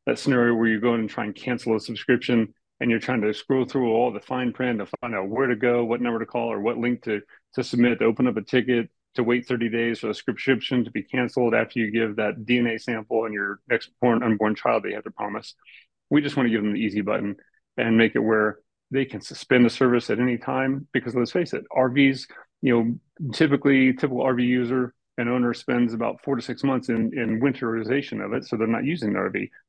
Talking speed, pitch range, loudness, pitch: 245 wpm, 115-130 Hz, -24 LUFS, 120 Hz